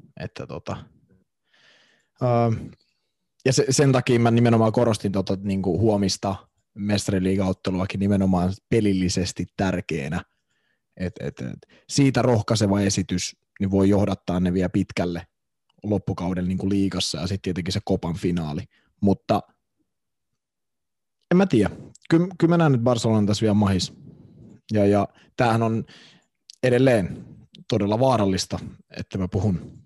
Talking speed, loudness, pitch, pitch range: 125 wpm, -23 LUFS, 100 Hz, 95-115 Hz